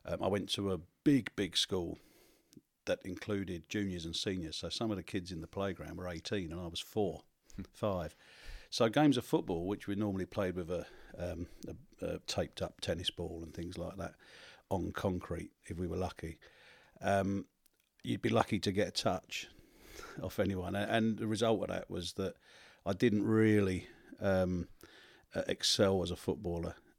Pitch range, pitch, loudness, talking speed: 90-105 Hz, 95 Hz, -36 LUFS, 180 wpm